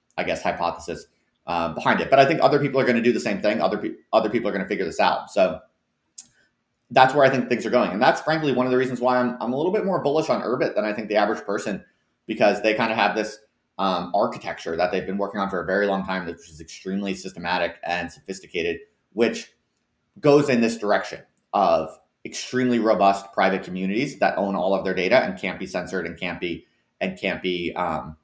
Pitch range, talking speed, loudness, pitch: 95-125 Hz, 235 wpm, -23 LUFS, 110 Hz